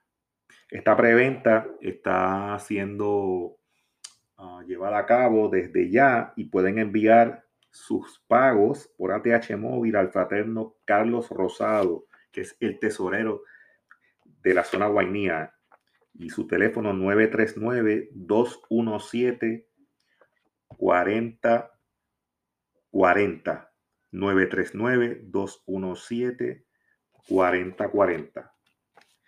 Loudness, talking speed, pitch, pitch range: -24 LUFS, 70 wpm, 110 Hz, 100-115 Hz